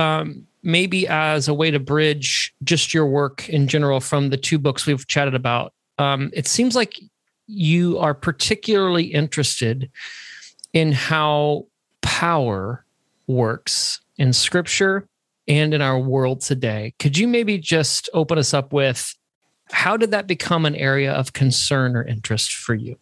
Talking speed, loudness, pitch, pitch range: 150 wpm, -19 LUFS, 145 Hz, 135-170 Hz